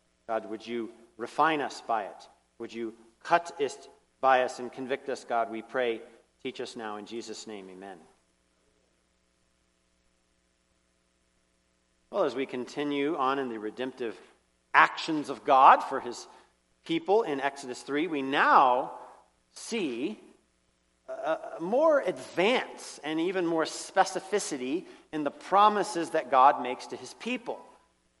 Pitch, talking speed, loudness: 120 Hz, 130 wpm, -28 LUFS